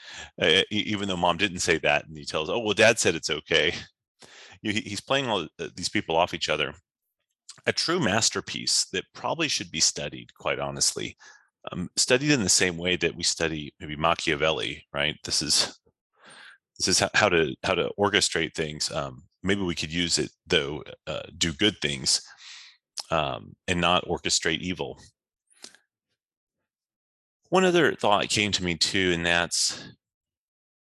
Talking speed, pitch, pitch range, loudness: 155 wpm, 85 Hz, 80-100 Hz, -25 LUFS